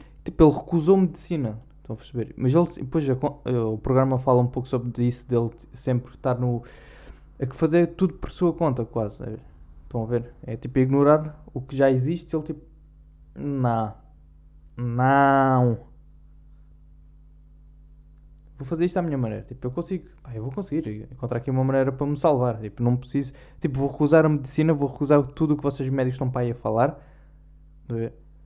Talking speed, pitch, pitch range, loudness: 185 wpm, 130 Hz, 110-145 Hz, -24 LUFS